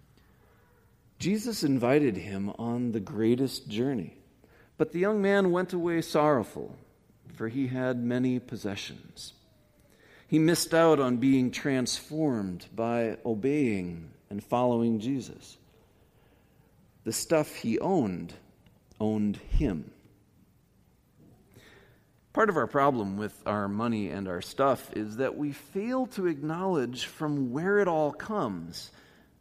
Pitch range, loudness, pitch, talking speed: 105-155 Hz, -29 LUFS, 125 Hz, 115 wpm